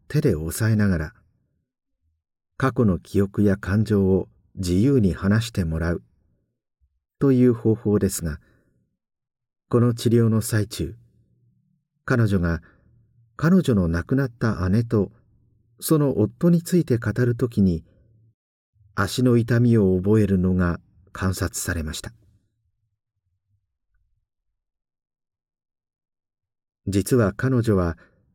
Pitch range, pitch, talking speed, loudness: 90-115 Hz, 105 Hz, 185 characters per minute, -22 LUFS